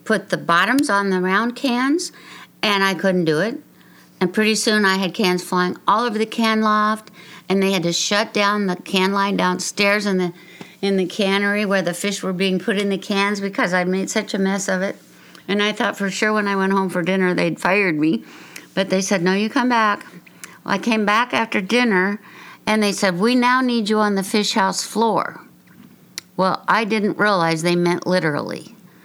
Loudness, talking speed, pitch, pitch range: -19 LUFS, 210 wpm, 200 Hz, 185-215 Hz